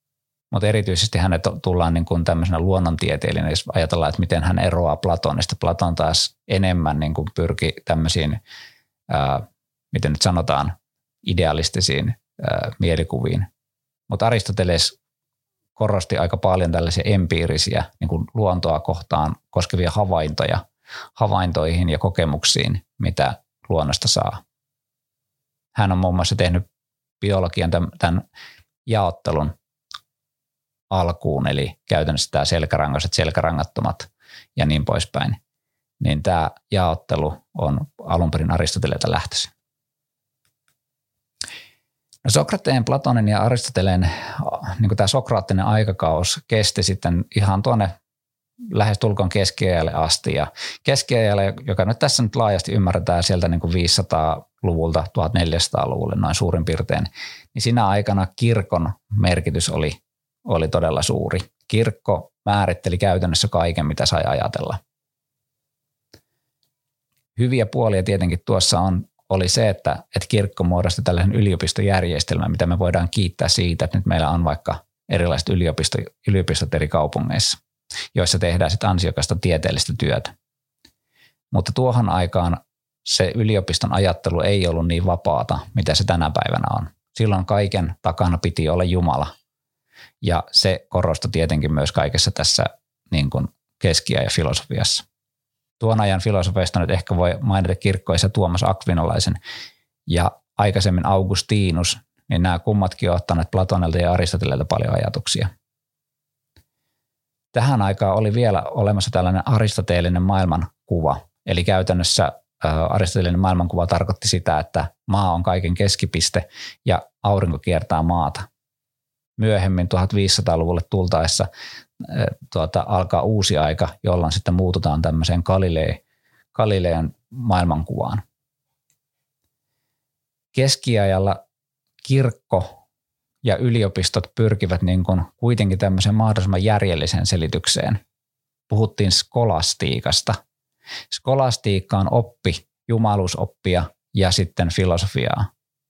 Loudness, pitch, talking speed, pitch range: -20 LUFS, 95 Hz, 110 wpm, 85-115 Hz